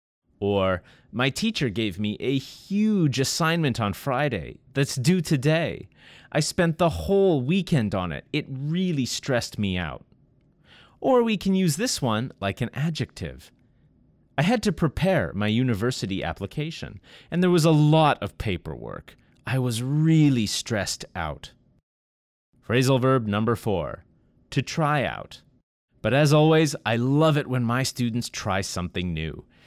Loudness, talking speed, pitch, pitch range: -24 LUFS, 145 wpm, 130 Hz, 105-160 Hz